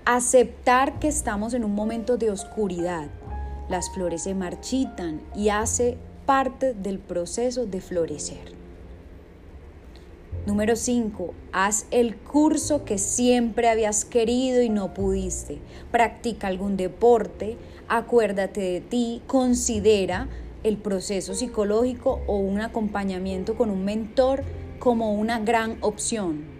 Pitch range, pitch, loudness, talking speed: 185-240 Hz, 215 Hz, -24 LUFS, 115 wpm